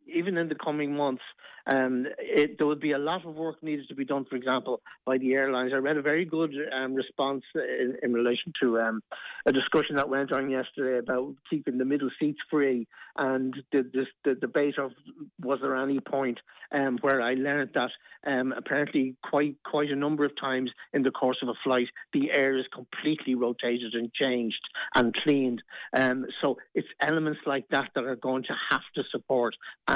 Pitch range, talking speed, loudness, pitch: 130-145 Hz, 195 wpm, -29 LUFS, 135 Hz